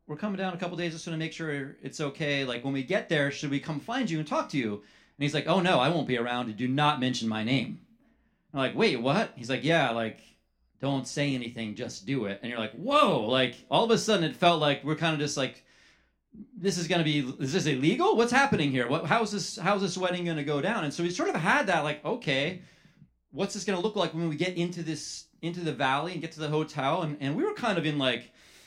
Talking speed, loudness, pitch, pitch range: 265 wpm, -28 LUFS, 155 Hz, 135-175 Hz